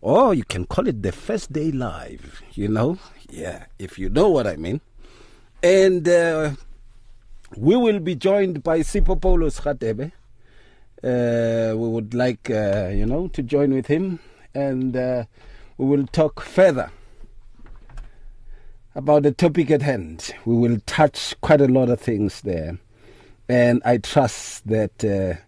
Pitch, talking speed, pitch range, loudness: 120 Hz, 150 wpm, 110-150 Hz, -21 LUFS